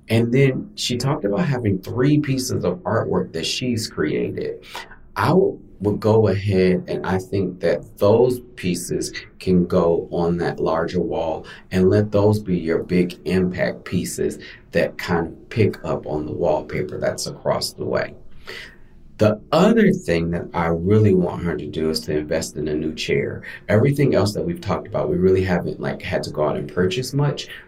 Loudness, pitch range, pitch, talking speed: -21 LUFS, 85-120 Hz, 95 Hz, 180 wpm